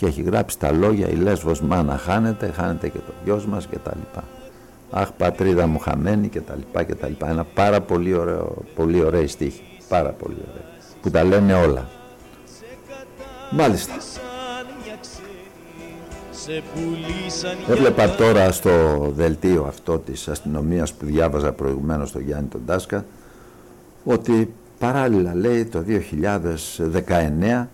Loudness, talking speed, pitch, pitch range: -21 LUFS, 130 wpm, 90 Hz, 80-110 Hz